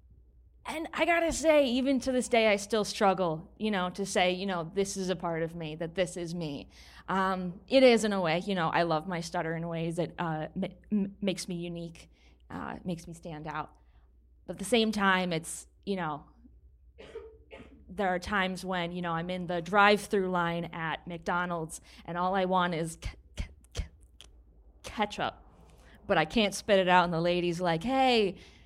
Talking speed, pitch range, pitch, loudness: 200 wpm, 165-200 Hz, 180 Hz, -30 LUFS